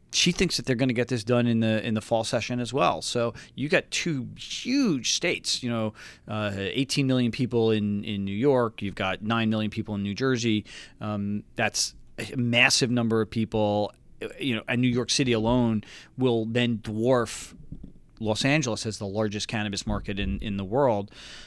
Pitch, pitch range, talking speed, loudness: 115 Hz, 105-125 Hz, 195 wpm, -26 LUFS